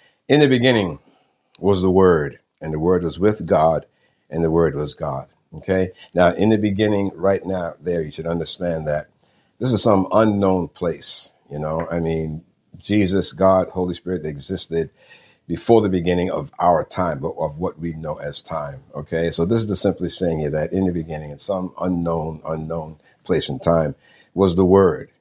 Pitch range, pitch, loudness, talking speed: 80-95 Hz, 90 Hz, -20 LUFS, 185 wpm